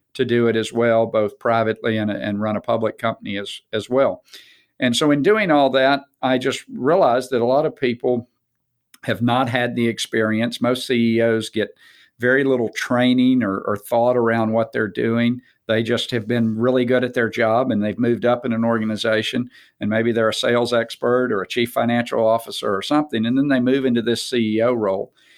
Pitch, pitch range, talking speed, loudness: 120 Hz, 110-125 Hz, 200 wpm, -20 LUFS